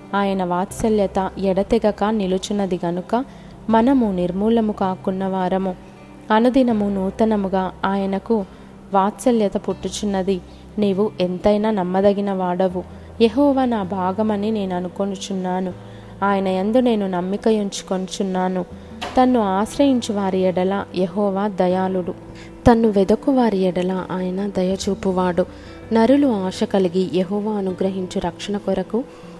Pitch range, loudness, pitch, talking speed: 185-215 Hz, -20 LUFS, 195 Hz, 95 wpm